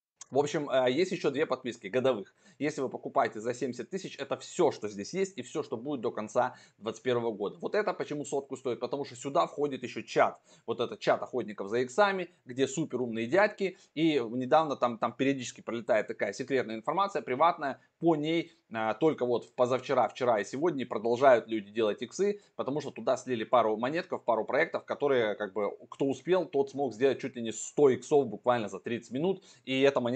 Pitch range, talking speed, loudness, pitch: 120-160 Hz, 195 wpm, -31 LUFS, 135 Hz